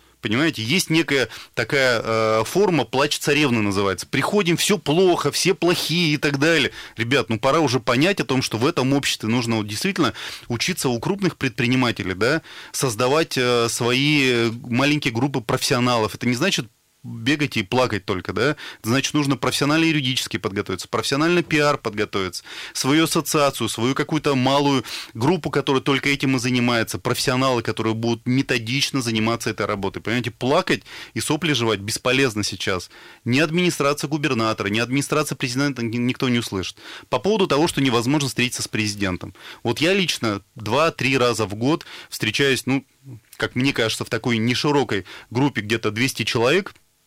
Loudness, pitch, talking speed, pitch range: -21 LUFS, 130 Hz, 150 wpm, 115-145 Hz